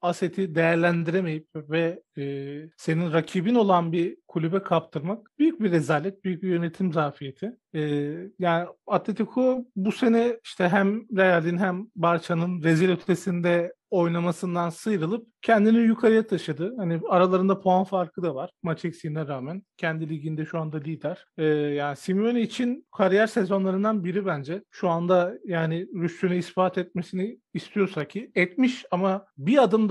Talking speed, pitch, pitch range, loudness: 140 wpm, 180 Hz, 165-200 Hz, -25 LUFS